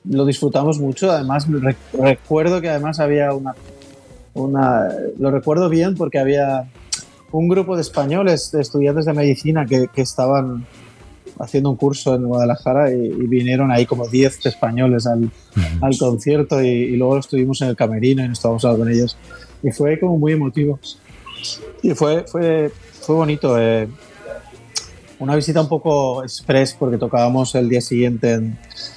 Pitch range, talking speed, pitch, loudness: 125-150 Hz, 155 wpm, 135 Hz, -18 LUFS